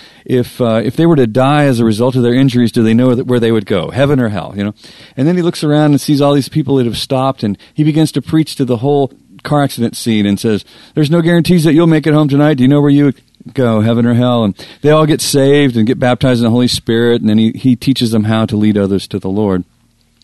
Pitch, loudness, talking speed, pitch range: 125 Hz, -12 LUFS, 285 wpm, 115-145 Hz